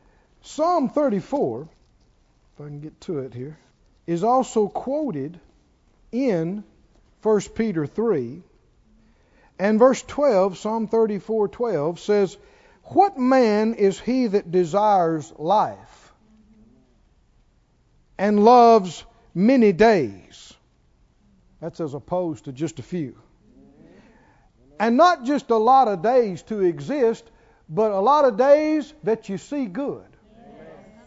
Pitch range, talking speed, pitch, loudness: 165-240 Hz, 115 wpm, 210 Hz, -21 LUFS